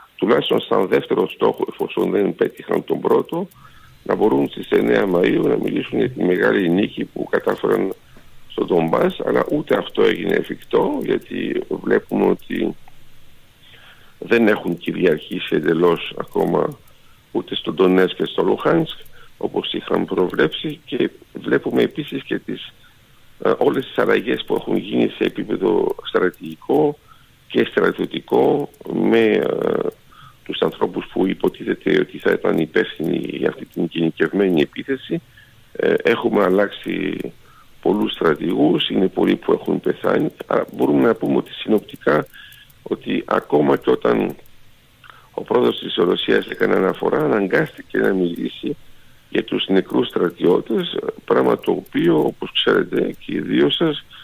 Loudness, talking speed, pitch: -19 LUFS, 130 wpm, 305 Hz